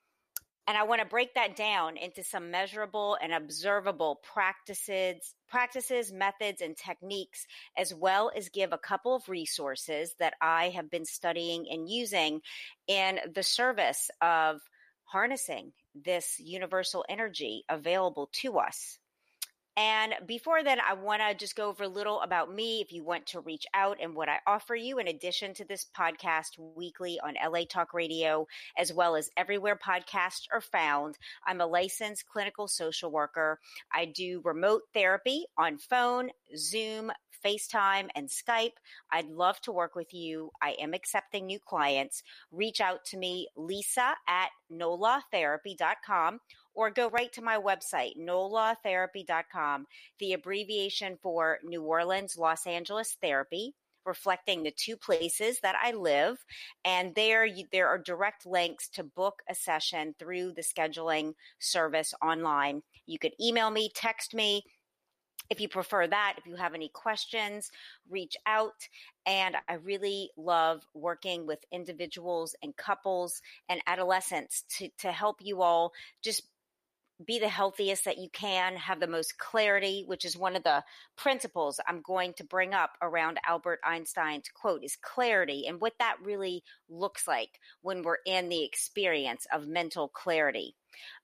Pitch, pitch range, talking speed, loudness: 185 Hz, 170-210 Hz, 150 wpm, -31 LUFS